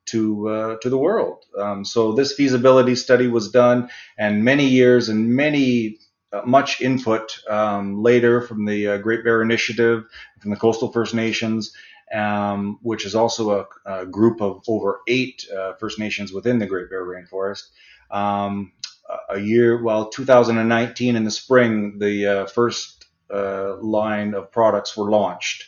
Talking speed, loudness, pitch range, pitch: 160 wpm, -20 LUFS, 100-120 Hz, 110 Hz